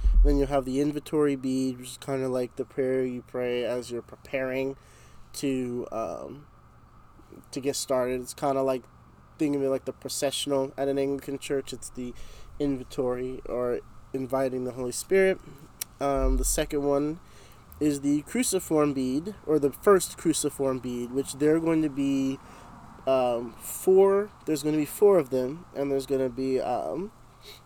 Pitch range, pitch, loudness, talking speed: 125-145 Hz, 135 Hz, -28 LUFS, 165 wpm